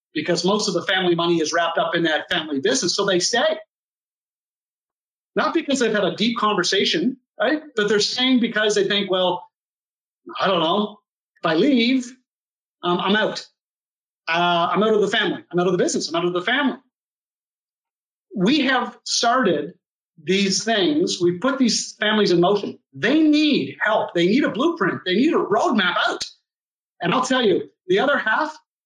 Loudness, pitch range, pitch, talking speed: -20 LUFS, 180-265 Hz, 210 Hz, 180 wpm